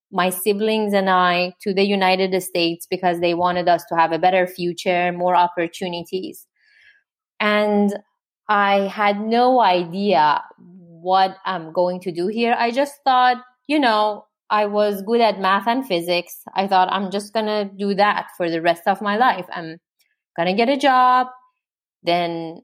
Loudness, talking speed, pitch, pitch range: -19 LUFS, 165 wpm, 195 Hz, 180-220 Hz